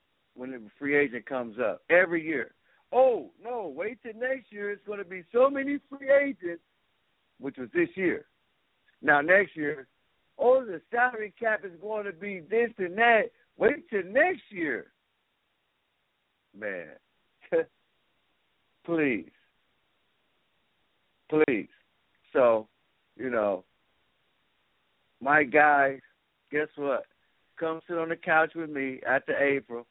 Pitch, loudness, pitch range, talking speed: 185 Hz, -27 LUFS, 150-240 Hz, 125 wpm